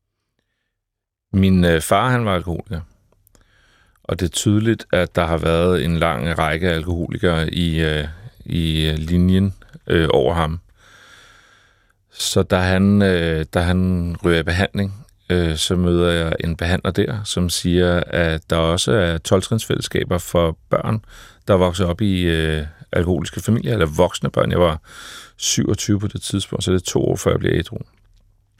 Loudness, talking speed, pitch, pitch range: -19 LUFS, 145 wpm, 90 Hz, 85-100 Hz